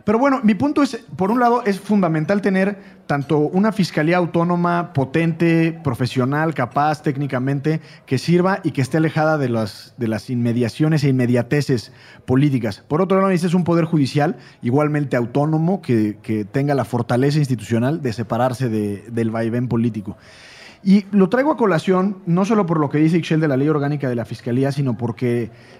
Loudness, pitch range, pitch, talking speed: -19 LUFS, 125-175 Hz, 150 Hz, 175 wpm